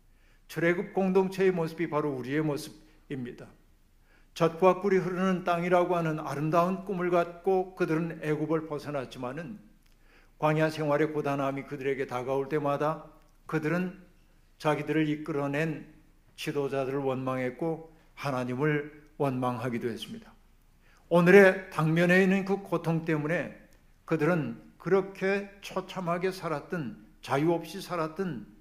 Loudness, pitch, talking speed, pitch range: -29 LUFS, 155 Hz, 290 characters per minute, 140-180 Hz